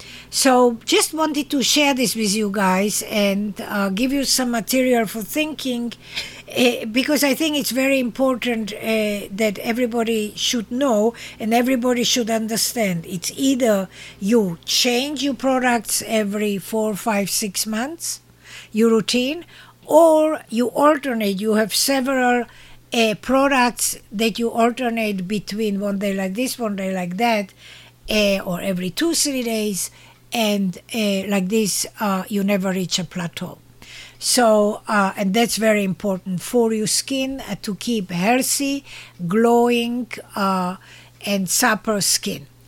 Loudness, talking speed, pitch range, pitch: -20 LUFS, 140 wpm, 200-250 Hz, 225 Hz